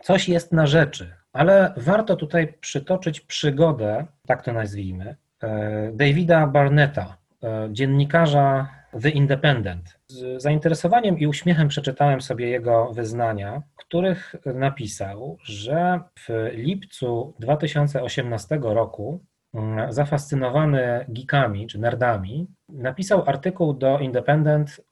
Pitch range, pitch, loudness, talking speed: 115-160 Hz, 140 Hz, -22 LUFS, 100 wpm